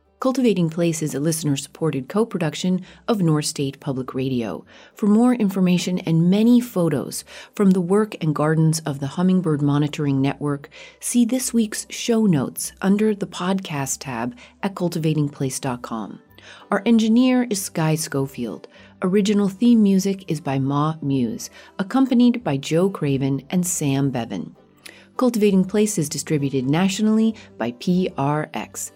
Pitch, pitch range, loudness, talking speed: 170 Hz, 145-205 Hz, -21 LUFS, 135 wpm